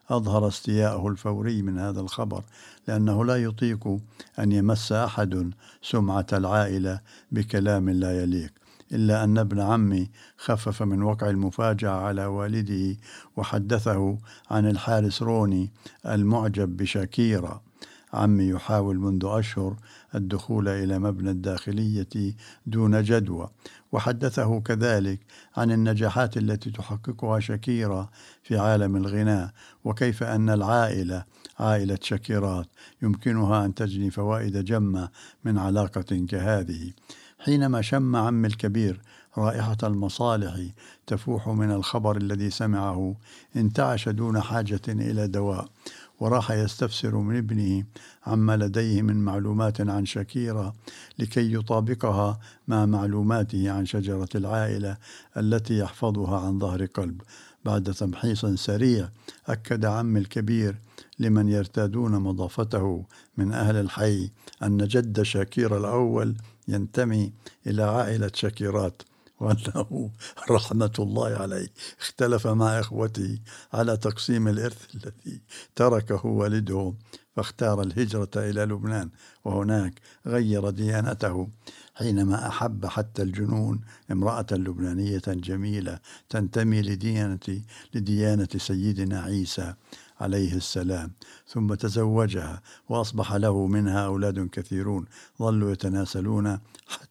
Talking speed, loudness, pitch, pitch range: 105 wpm, -26 LUFS, 105 Hz, 100-110 Hz